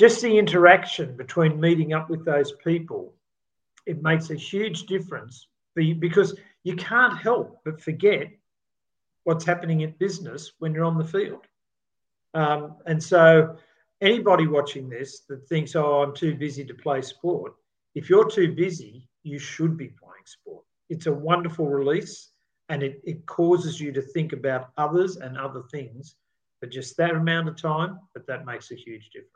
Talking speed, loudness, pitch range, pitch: 165 wpm, -23 LUFS, 145-180 Hz, 160 Hz